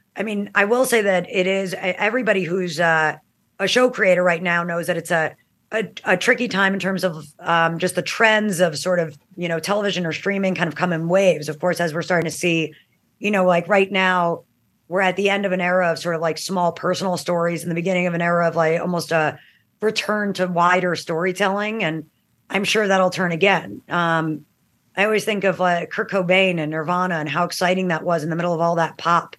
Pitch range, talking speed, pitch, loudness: 170-195 Hz, 230 wpm, 180 Hz, -20 LUFS